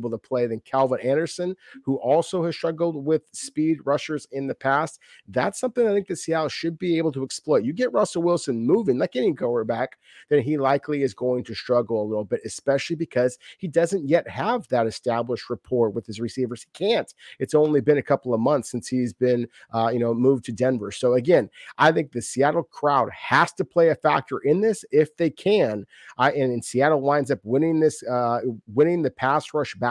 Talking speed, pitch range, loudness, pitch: 215 wpm, 120-160 Hz, -23 LUFS, 140 Hz